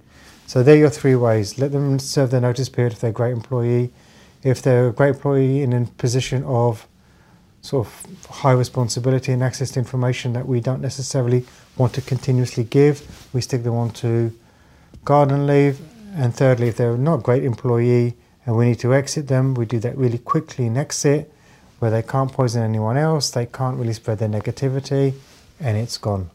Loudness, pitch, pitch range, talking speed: -20 LUFS, 125 Hz, 120-135 Hz, 195 wpm